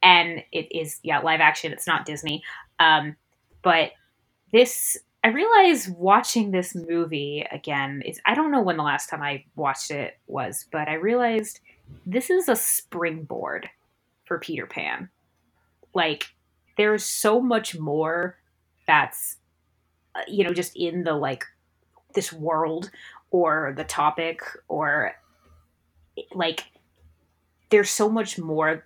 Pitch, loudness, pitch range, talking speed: 160 Hz, -23 LUFS, 135-190 Hz, 130 wpm